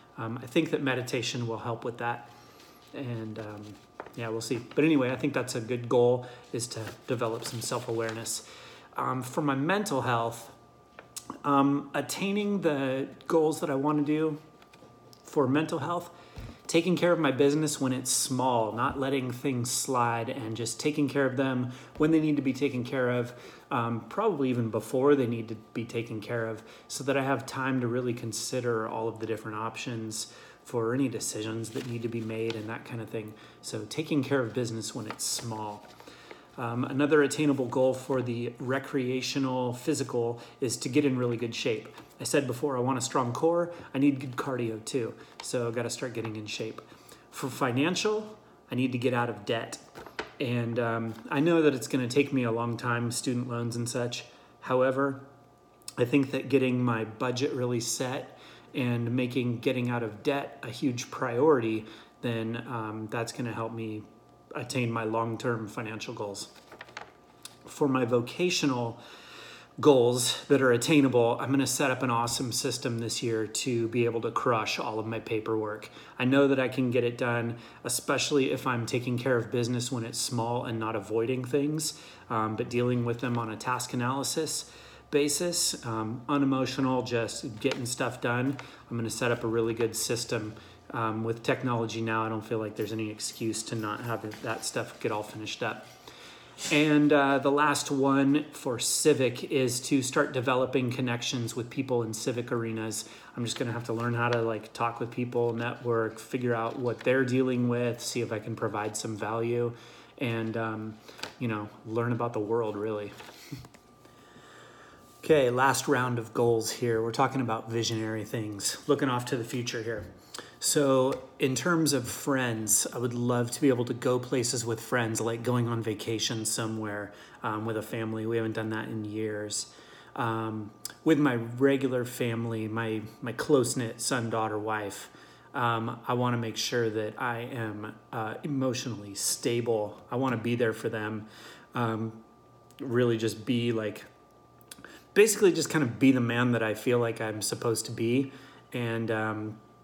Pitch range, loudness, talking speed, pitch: 115-135 Hz, -29 LUFS, 180 wpm, 120 Hz